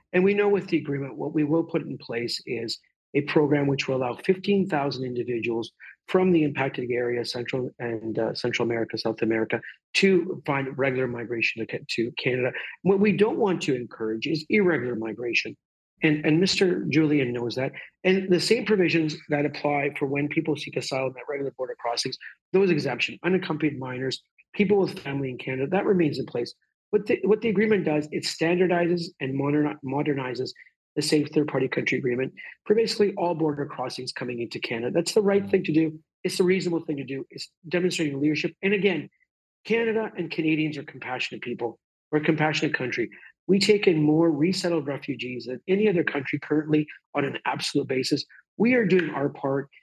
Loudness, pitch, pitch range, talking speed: -25 LUFS, 150 Hz, 130-175 Hz, 185 wpm